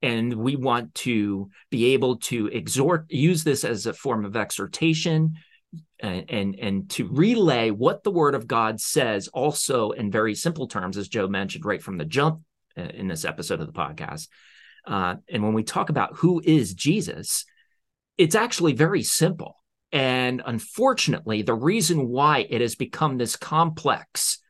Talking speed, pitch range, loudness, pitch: 165 wpm, 115-160 Hz, -24 LUFS, 130 Hz